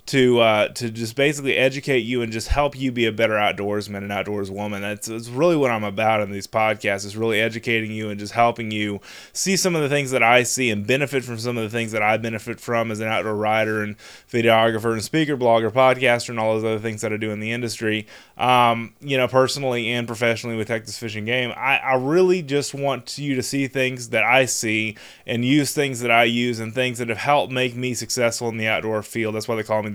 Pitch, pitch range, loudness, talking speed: 115 Hz, 110-130 Hz, -21 LUFS, 240 wpm